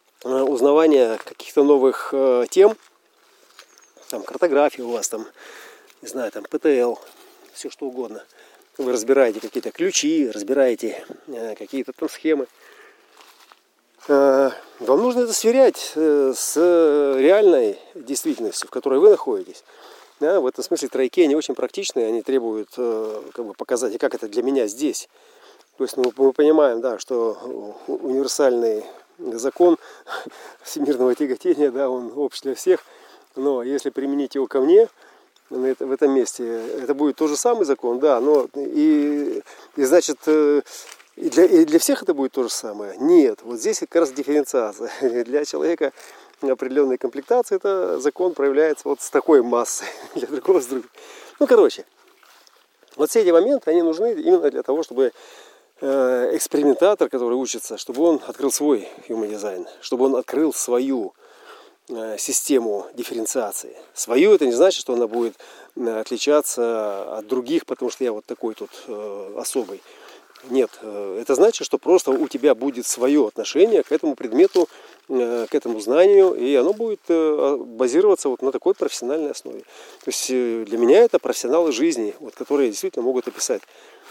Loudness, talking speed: -20 LUFS, 145 wpm